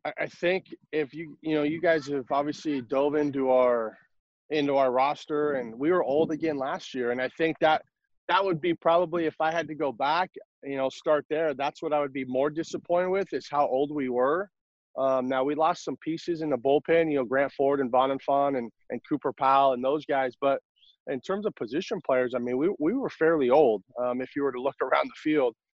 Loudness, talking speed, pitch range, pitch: -27 LUFS, 230 wpm, 135-160 Hz, 145 Hz